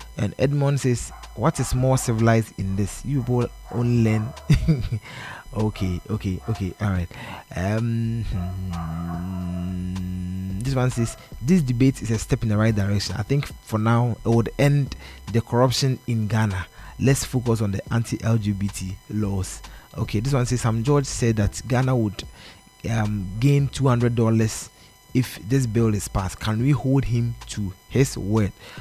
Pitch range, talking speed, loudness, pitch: 100-125 Hz, 150 wpm, -23 LUFS, 110 Hz